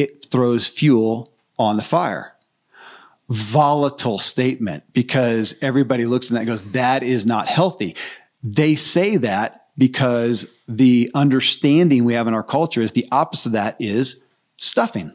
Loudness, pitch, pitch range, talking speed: -18 LUFS, 125 Hz, 115-140 Hz, 150 wpm